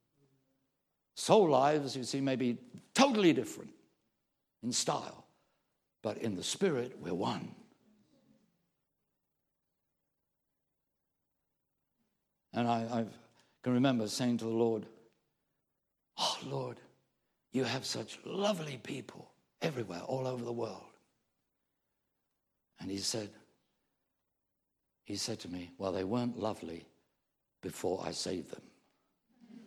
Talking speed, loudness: 105 wpm, -35 LUFS